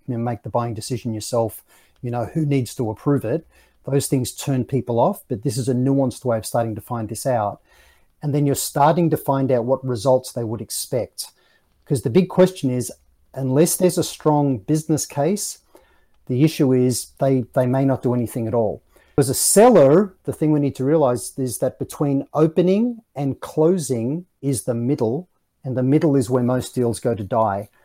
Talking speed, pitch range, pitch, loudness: 200 wpm, 120-145 Hz, 130 Hz, -20 LUFS